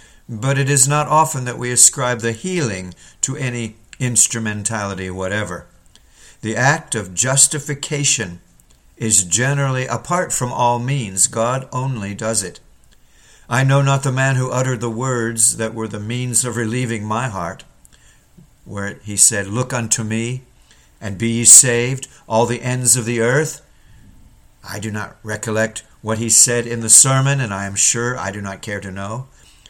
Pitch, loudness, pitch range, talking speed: 115 Hz, -16 LUFS, 105-130 Hz, 165 wpm